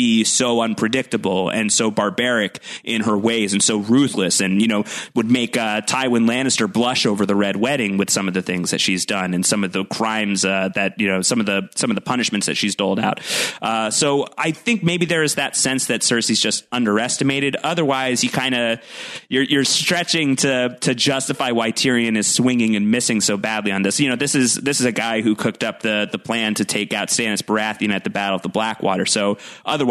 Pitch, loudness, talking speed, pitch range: 115 Hz, -18 LUFS, 225 wpm, 105-130 Hz